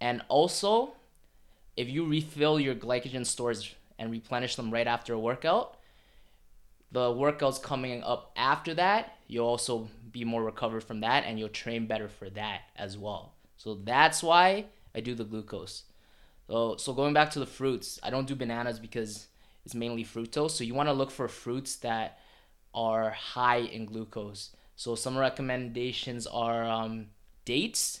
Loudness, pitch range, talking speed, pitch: -30 LUFS, 110-130 Hz, 160 wpm, 120 Hz